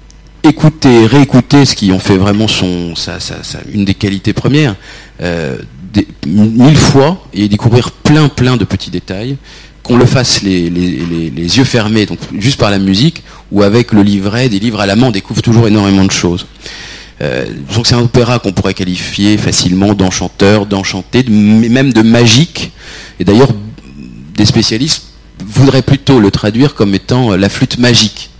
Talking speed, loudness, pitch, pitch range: 175 wpm, -9 LUFS, 105 Hz, 95-125 Hz